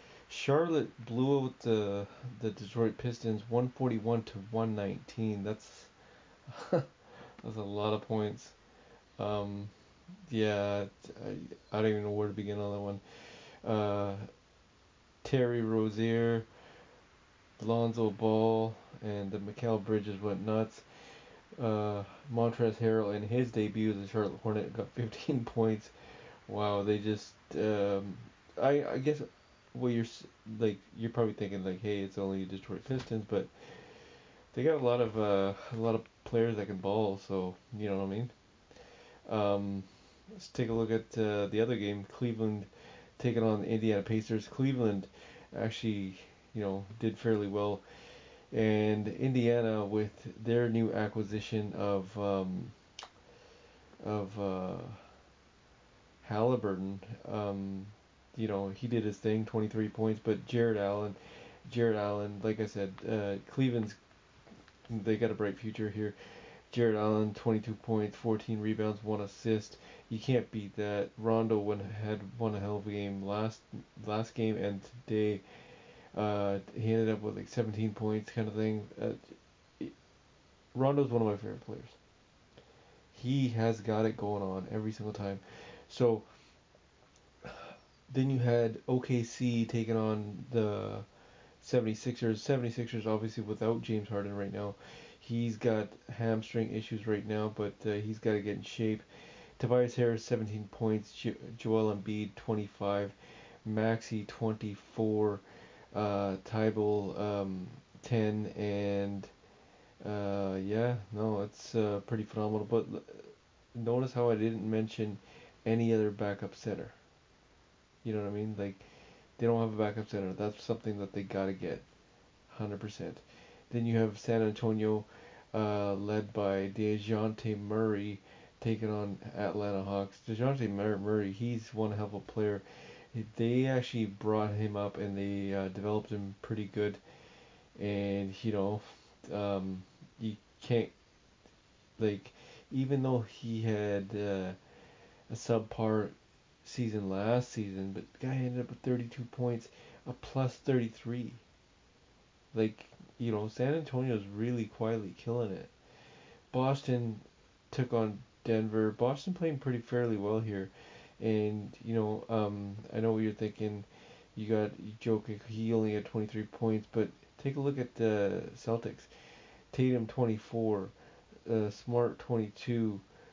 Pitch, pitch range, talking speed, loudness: 110 Hz, 100-115 Hz, 135 wpm, -35 LUFS